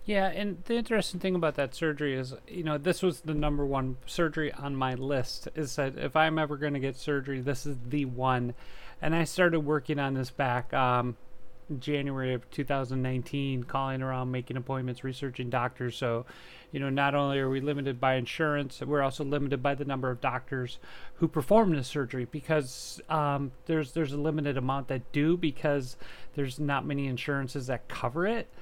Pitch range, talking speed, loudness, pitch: 130-150 Hz, 185 wpm, -31 LUFS, 140 Hz